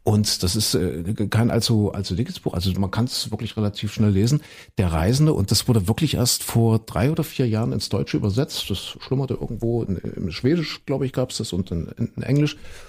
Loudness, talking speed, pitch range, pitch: -22 LUFS, 210 wpm, 100-125 Hz, 115 Hz